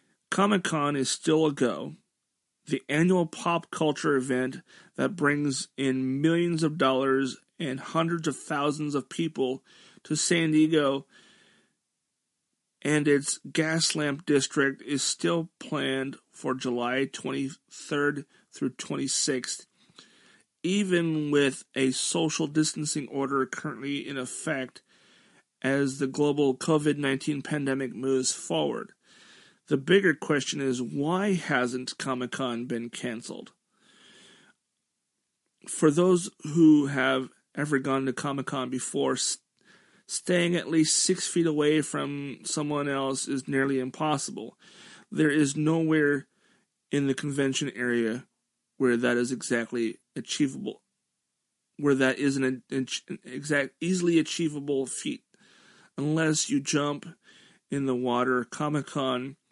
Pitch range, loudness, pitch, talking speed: 130-155 Hz, -27 LUFS, 145 Hz, 115 wpm